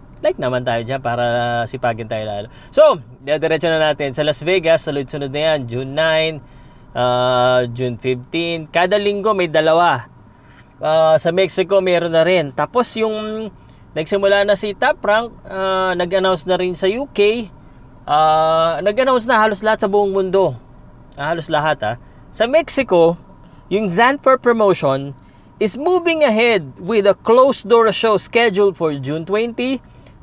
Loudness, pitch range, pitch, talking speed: -16 LUFS, 140-215 Hz, 170 Hz, 150 wpm